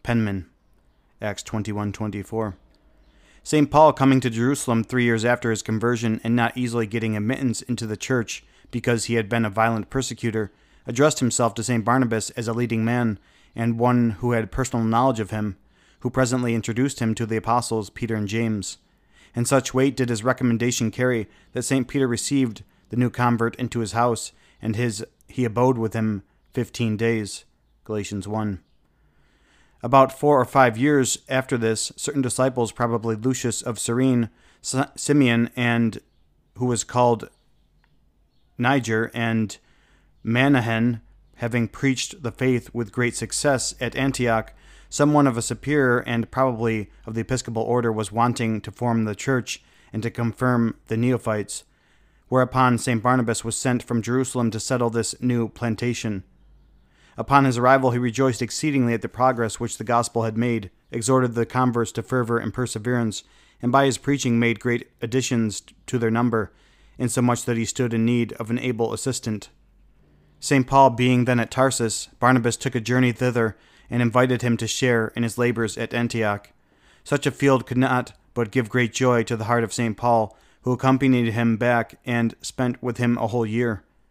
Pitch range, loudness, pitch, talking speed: 115-125 Hz, -22 LUFS, 120 Hz, 165 wpm